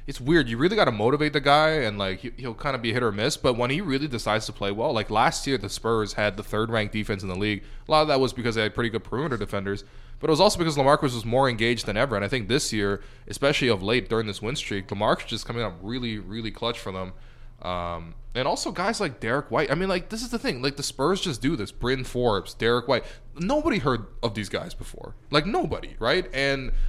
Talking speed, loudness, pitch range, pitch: 260 wpm, -25 LUFS, 105-140 Hz, 120 Hz